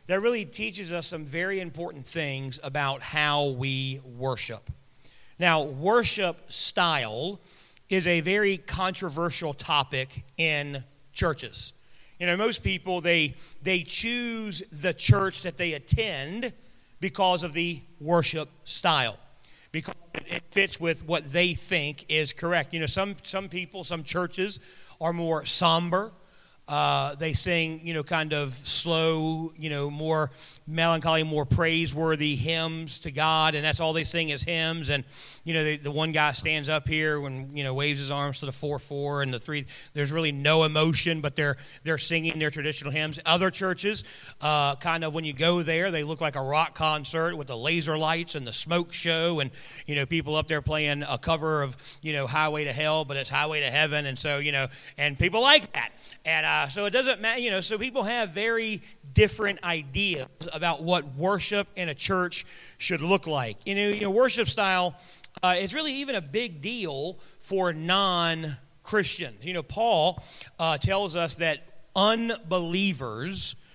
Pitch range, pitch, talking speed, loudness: 145-180 Hz, 160 Hz, 170 wpm, -26 LUFS